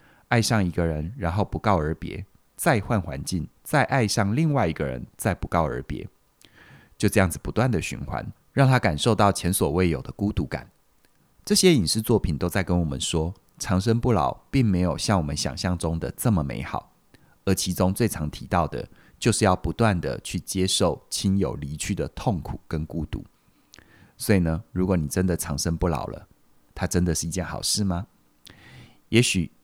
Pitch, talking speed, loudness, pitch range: 90 Hz, 265 characters per minute, -24 LUFS, 80-105 Hz